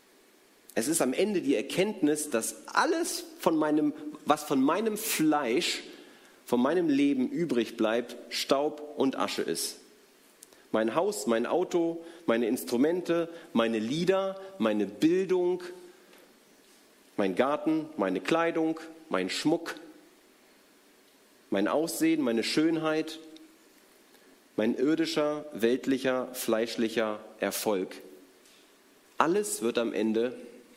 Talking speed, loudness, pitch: 100 wpm, -29 LUFS, 155 Hz